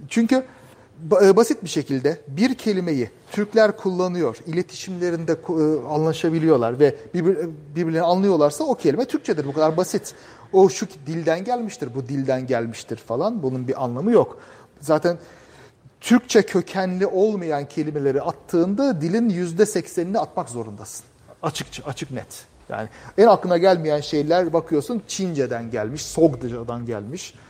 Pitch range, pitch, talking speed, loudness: 140-190 Hz, 165 Hz, 120 wpm, -21 LUFS